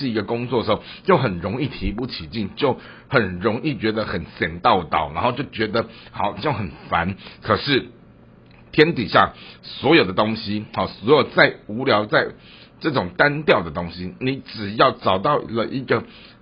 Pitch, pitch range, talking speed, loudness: 110 Hz, 90-115 Hz, 245 characters per minute, -21 LUFS